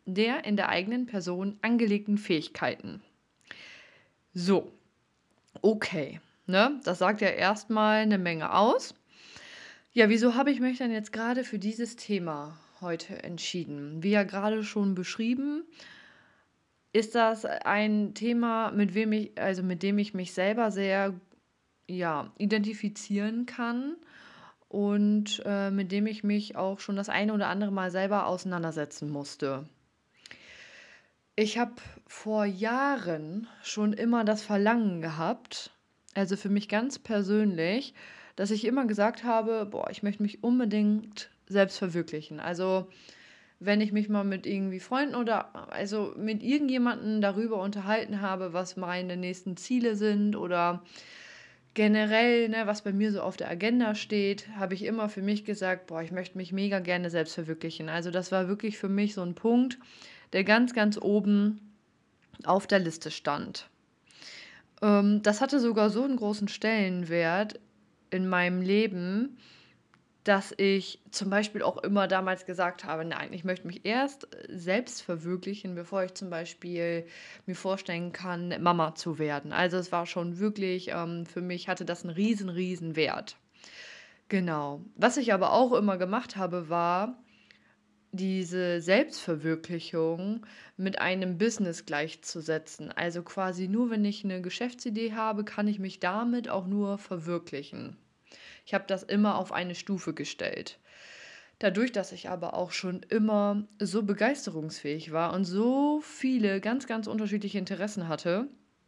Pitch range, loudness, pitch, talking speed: 180-215 Hz, -30 LUFS, 200 Hz, 145 wpm